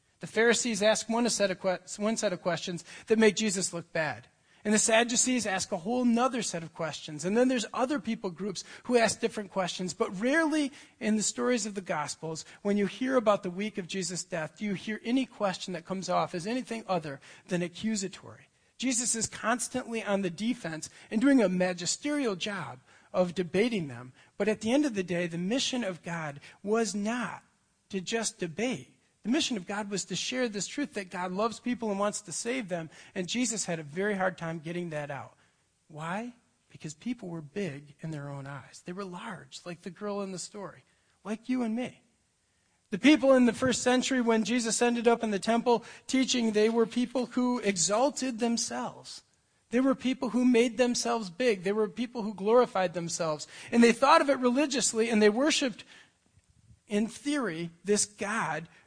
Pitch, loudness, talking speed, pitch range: 210 Hz, -29 LUFS, 195 wpm, 180-240 Hz